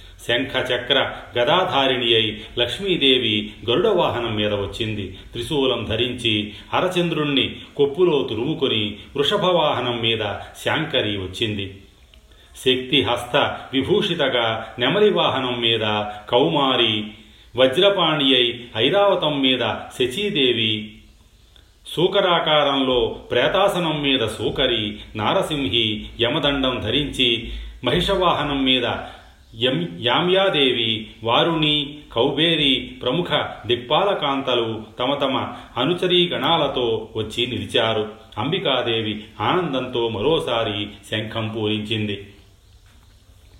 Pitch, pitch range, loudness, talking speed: 120 Hz, 105-140 Hz, -20 LUFS, 70 wpm